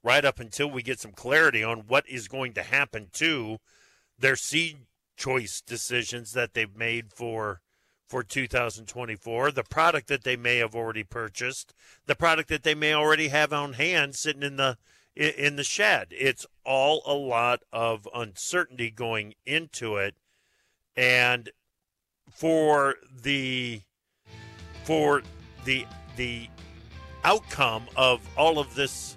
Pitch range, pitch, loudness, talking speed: 110-140 Hz, 125 Hz, -26 LUFS, 140 wpm